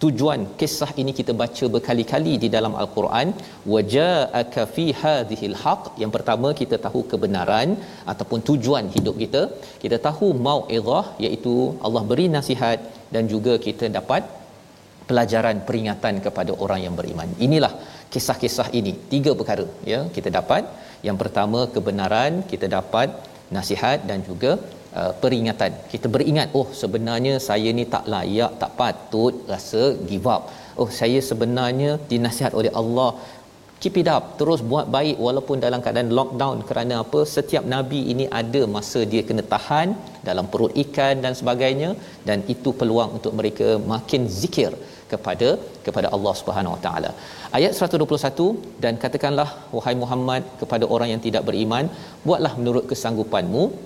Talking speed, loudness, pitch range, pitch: 140 wpm, -22 LUFS, 115-145 Hz, 125 Hz